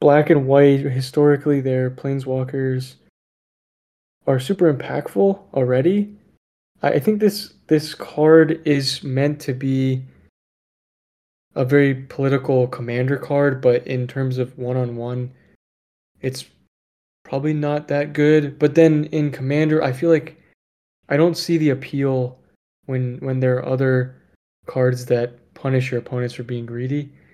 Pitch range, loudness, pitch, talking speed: 125-150 Hz, -19 LUFS, 135 Hz, 135 wpm